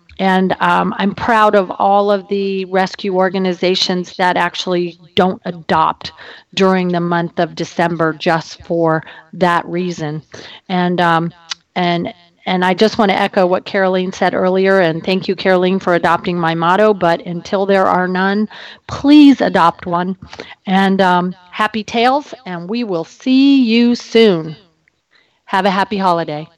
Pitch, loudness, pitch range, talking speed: 185 Hz, -14 LUFS, 175-200 Hz, 150 wpm